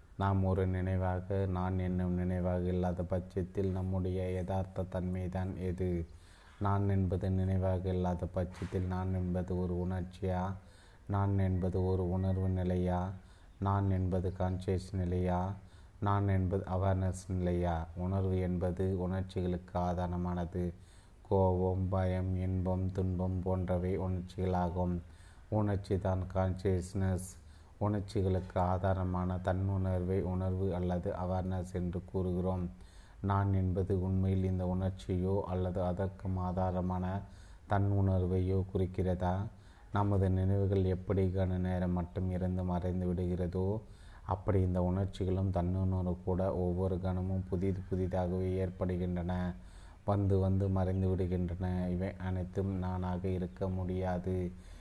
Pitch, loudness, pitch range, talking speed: 95 Hz, -34 LUFS, 90-95 Hz, 105 wpm